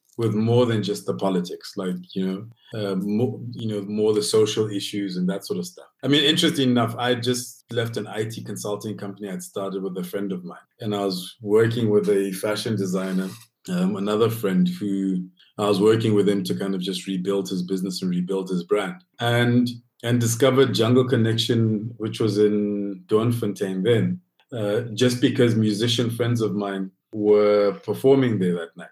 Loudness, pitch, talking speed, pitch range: -23 LUFS, 105 Hz, 185 wpm, 100-120 Hz